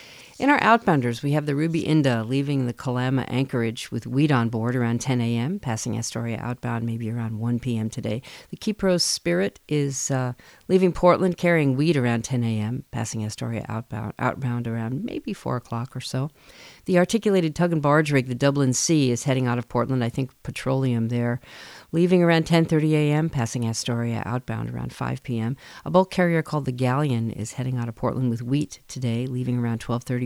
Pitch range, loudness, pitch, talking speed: 115-150 Hz, -24 LUFS, 125 Hz, 185 wpm